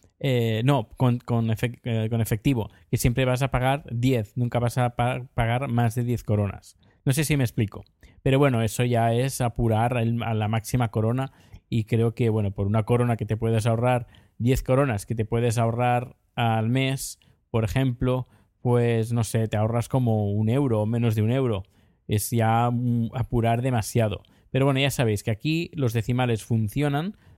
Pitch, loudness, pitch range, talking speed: 120 Hz, -25 LUFS, 110-125 Hz, 180 wpm